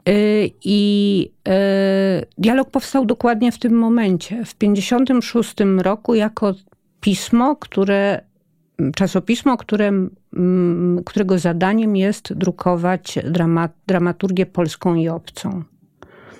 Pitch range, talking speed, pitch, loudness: 180-215 Hz, 85 wpm, 195 Hz, -18 LUFS